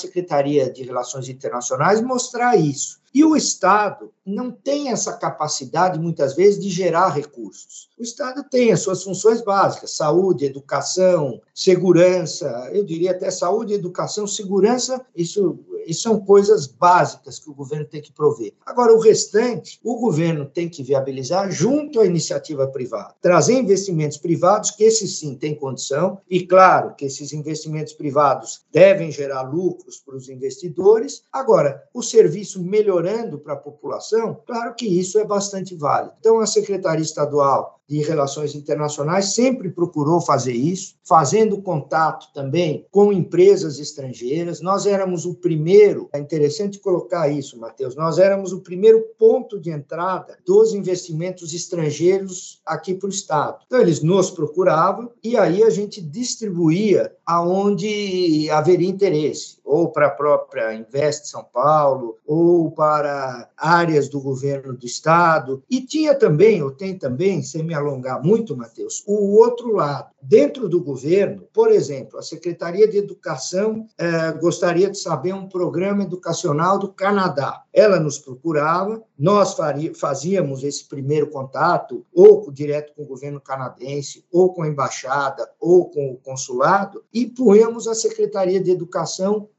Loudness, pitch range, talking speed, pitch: -19 LUFS, 150-205 Hz, 145 wpm, 180 Hz